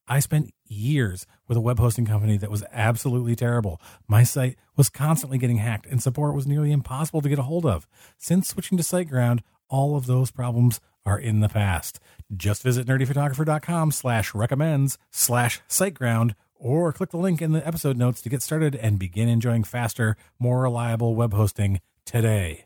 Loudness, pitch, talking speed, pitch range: -24 LUFS, 120 Hz, 165 wpm, 110-145 Hz